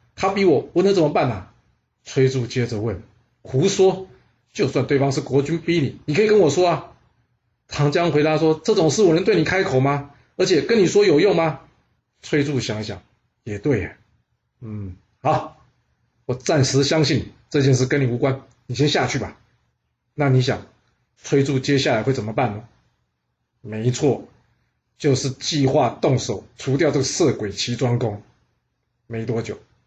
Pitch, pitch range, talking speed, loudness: 130 Hz, 115-150 Hz, 235 characters per minute, -20 LUFS